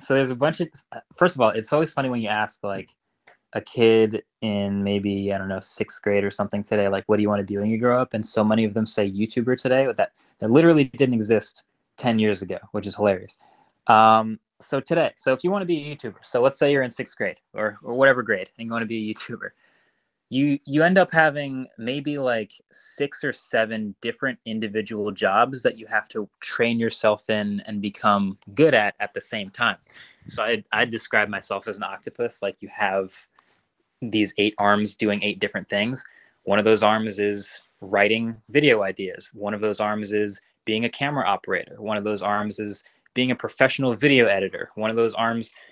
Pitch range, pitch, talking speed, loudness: 105-130 Hz, 110 Hz, 215 wpm, -23 LUFS